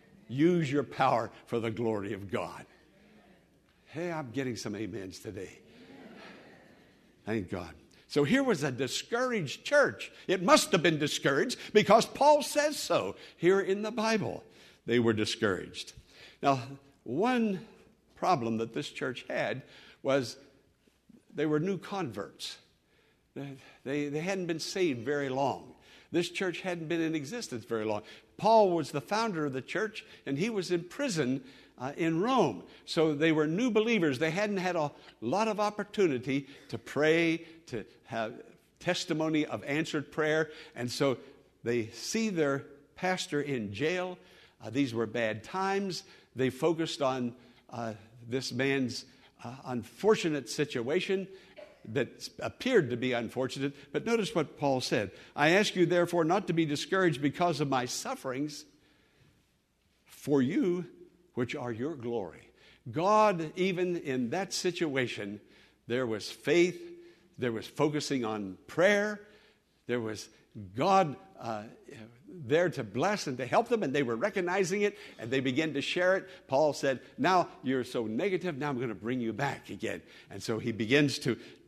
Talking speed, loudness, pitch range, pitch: 150 wpm, -31 LUFS, 125-180 Hz, 150 Hz